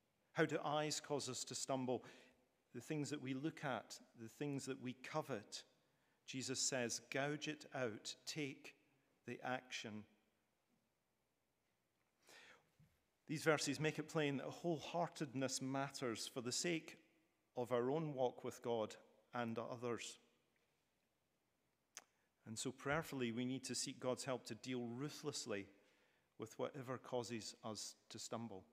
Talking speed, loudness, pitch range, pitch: 130 wpm, -45 LUFS, 120-145 Hz, 130 Hz